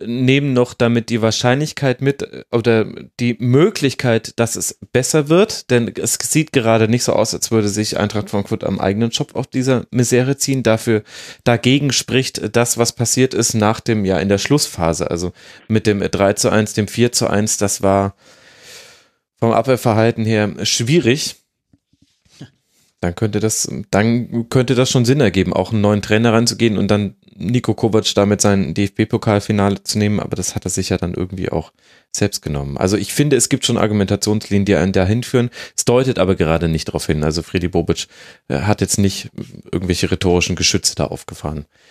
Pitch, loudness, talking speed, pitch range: 110 Hz, -17 LUFS, 175 wpm, 100-120 Hz